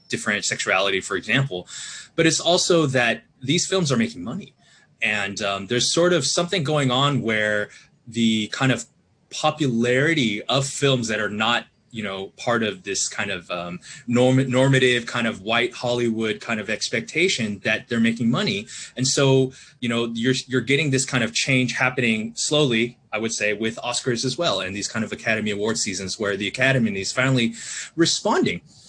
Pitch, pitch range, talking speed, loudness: 120 Hz, 110-135 Hz, 175 wpm, -21 LUFS